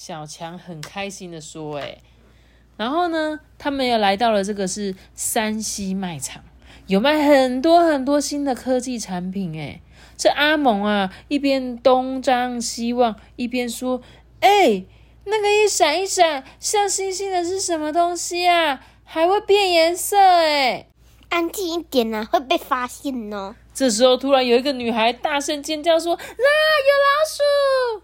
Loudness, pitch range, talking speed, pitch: -19 LUFS, 220-335 Hz, 220 characters per minute, 275 Hz